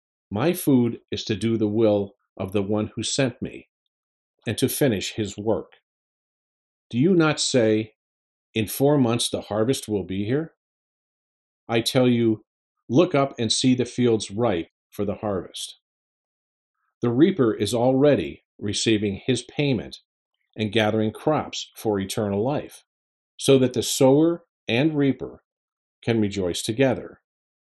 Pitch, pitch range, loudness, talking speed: 110 Hz, 105-130 Hz, -23 LUFS, 140 wpm